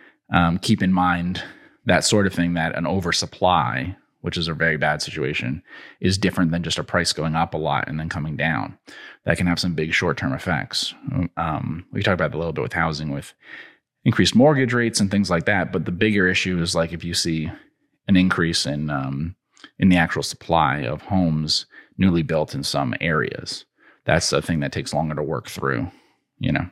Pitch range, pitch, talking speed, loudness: 80-95 Hz, 85 Hz, 205 wpm, -21 LUFS